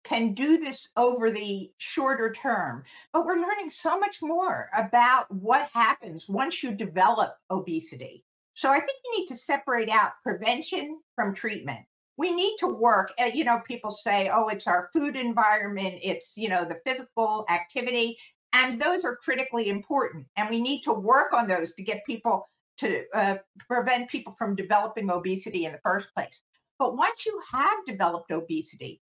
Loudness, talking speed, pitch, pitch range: -27 LUFS, 170 wpm, 235 Hz, 200-280 Hz